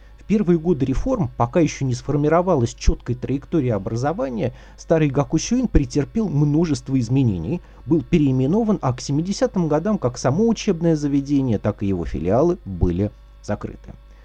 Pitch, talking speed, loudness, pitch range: 145 Hz, 130 wpm, -21 LUFS, 125-175 Hz